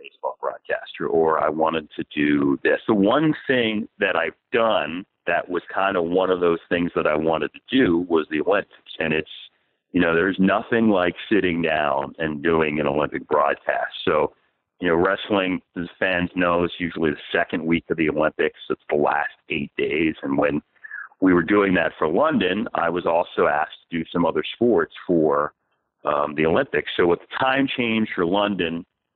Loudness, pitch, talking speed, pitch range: -22 LUFS, 85 Hz, 190 wpm, 80-105 Hz